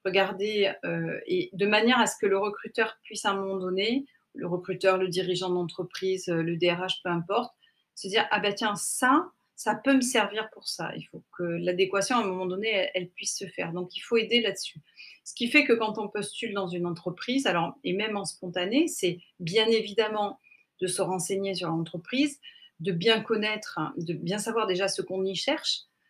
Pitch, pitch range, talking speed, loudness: 195 Hz, 185-220 Hz, 200 wpm, -28 LUFS